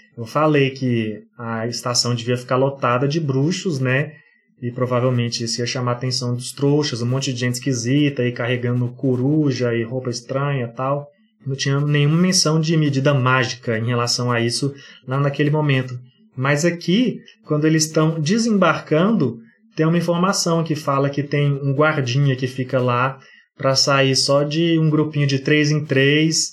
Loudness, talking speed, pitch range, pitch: -19 LUFS, 165 wpm, 125-150 Hz, 135 Hz